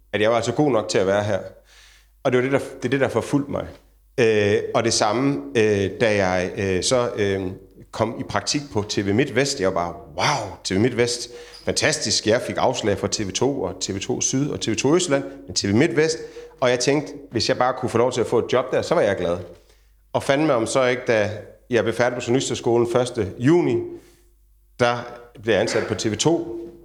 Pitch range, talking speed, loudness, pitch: 105-135 Hz, 215 wpm, -21 LUFS, 120 Hz